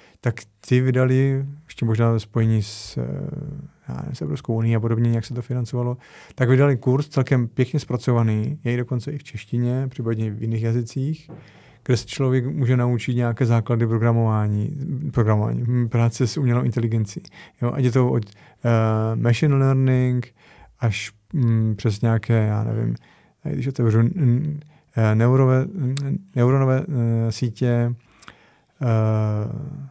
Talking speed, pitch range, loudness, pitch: 135 wpm, 115-130 Hz, -22 LUFS, 120 Hz